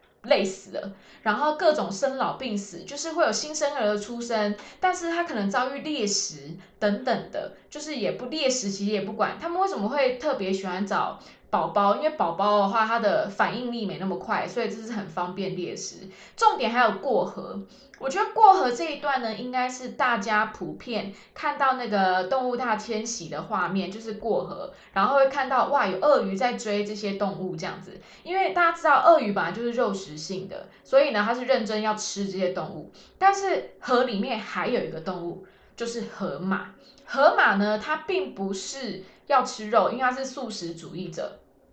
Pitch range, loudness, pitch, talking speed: 195-270 Hz, -25 LUFS, 220 Hz, 290 characters per minute